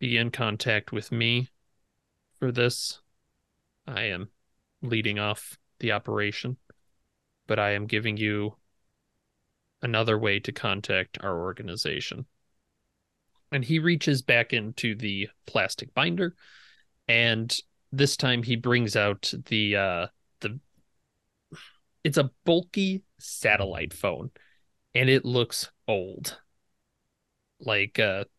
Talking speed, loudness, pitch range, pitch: 110 wpm, -27 LUFS, 105-130 Hz, 115 Hz